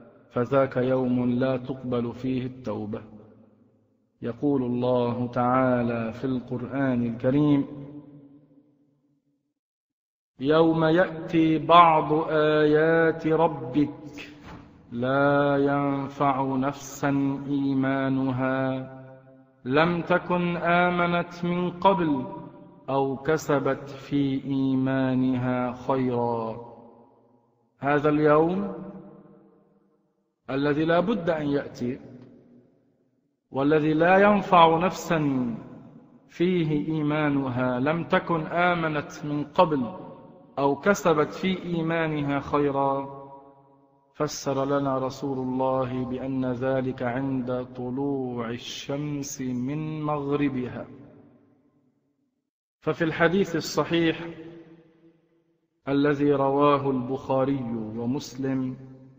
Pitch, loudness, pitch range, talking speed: 140 Hz, -25 LUFS, 130-155 Hz, 75 wpm